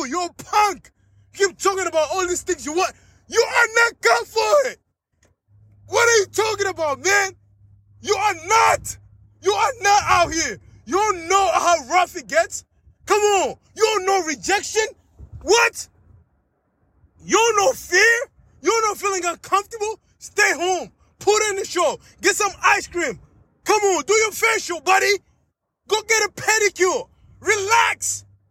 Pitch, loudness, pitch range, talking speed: 390 Hz, -19 LUFS, 335-425 Hz, 160 wpm